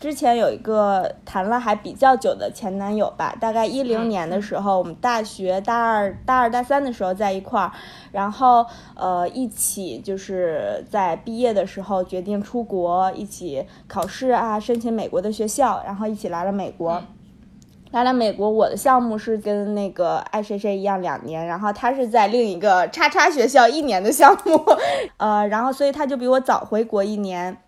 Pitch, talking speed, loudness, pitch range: 210 Hz, 275 characters per minute, -20 LUFS, 195-240 Hz